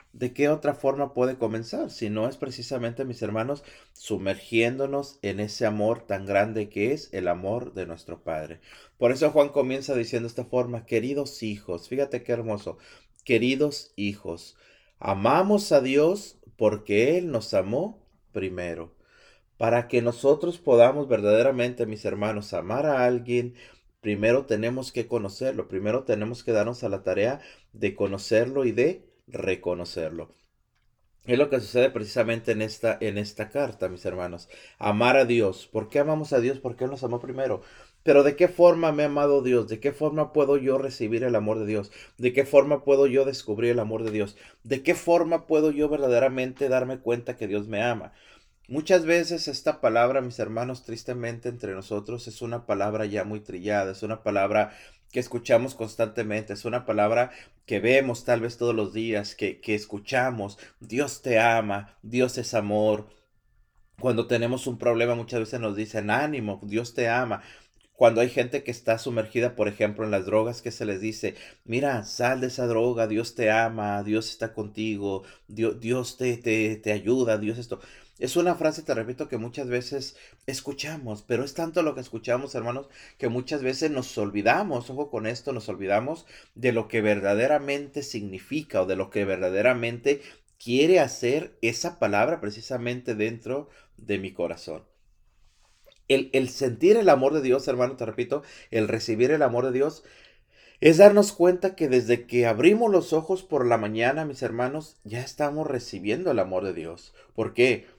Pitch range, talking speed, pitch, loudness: 110-135 Hz, 170 wpm, 120 Hz, -25 LUFS